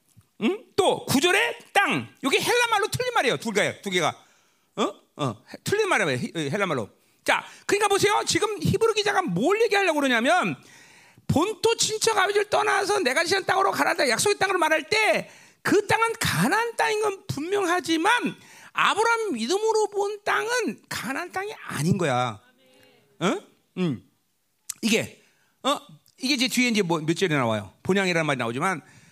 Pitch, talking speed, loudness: 380 Hz, 320 characters per minute, -24 LUFS